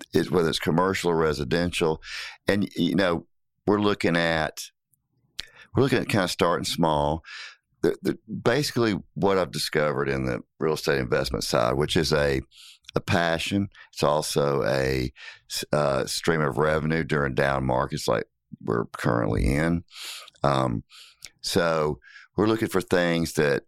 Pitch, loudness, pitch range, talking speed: 80 Hz, -25 LUFS, 70-95 Hz, 145 wpm